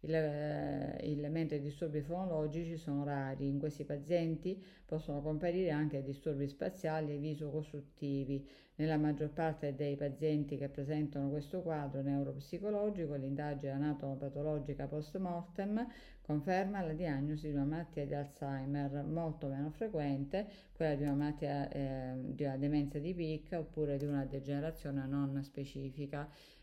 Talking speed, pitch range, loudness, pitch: 135 wpm, 140-160 Hz, -39 LUFS, 150 Hz